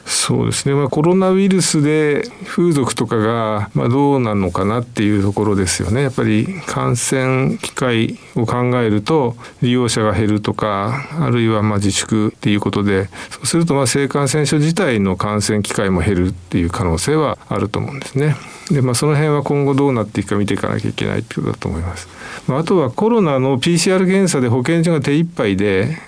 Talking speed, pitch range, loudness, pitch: 400 characters per minute, 105-145 Hz, -16 LUFS, 125 Hz